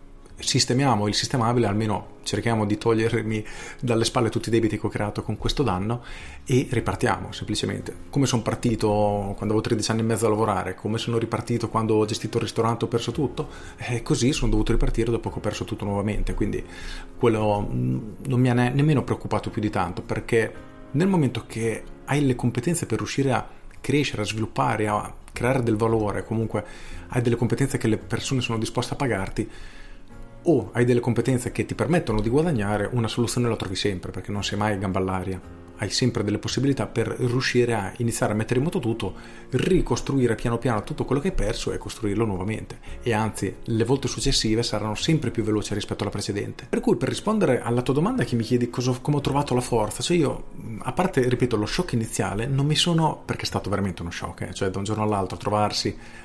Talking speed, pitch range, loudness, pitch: 200 wpm, 105-125 Hz, -24 LUFS, 115 Hz